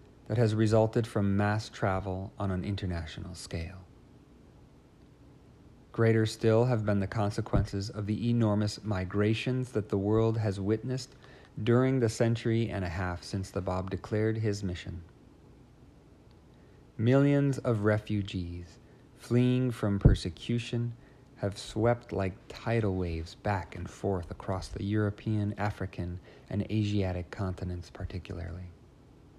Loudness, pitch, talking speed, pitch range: -31 LUFS, 105 Hz, 120 wpm, 95-115 Hz